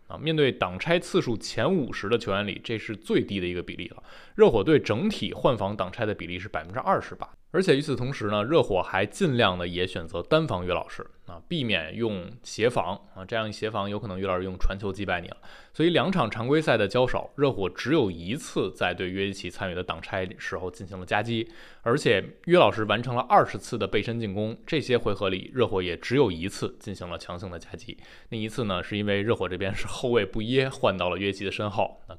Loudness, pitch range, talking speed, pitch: -27 LUFS, 95-115 Hz, 340 characters per minute, 105 Hz